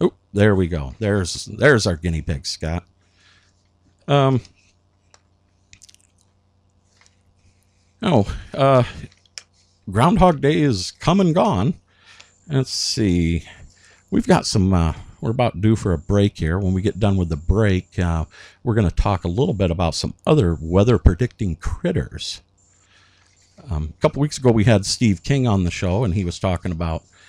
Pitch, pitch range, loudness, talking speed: 100 Hz, 90-105 Hz, -20 LUFS, 155 wpm